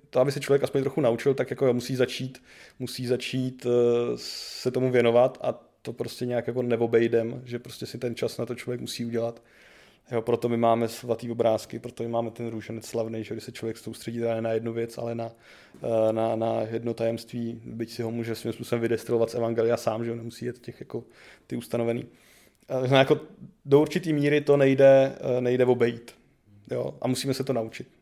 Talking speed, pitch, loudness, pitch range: 205 wpm, 120 Hz, -26 LUFS, 115-125 Hz